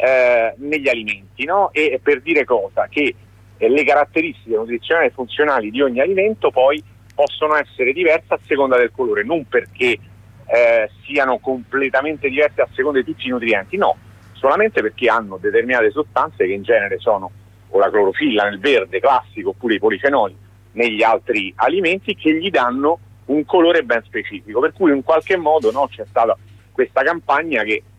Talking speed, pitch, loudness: 170 wpm, 150 Hz, -17 LUFS